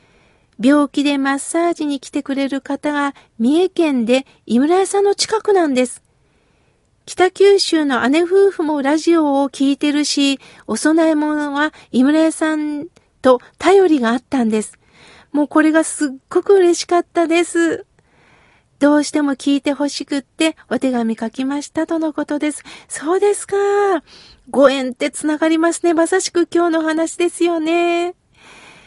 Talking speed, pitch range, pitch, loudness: 290 characters per minute, 280-340 Hz, 300 Hz, -16 LUFS